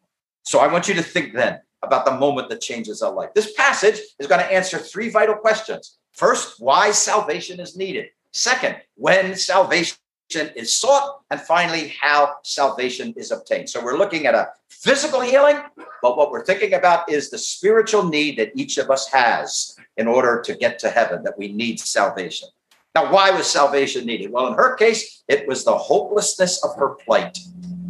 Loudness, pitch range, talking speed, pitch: -19 LUFS, 165-225 Hz, 185 wpm, 190 Hz